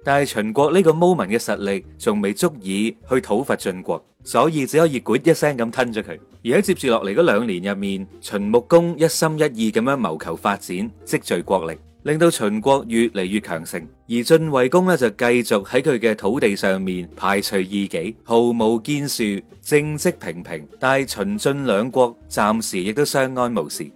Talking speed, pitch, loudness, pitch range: 285 characters per minute, 120 Hz, -20 LUFS, 100-145 Hz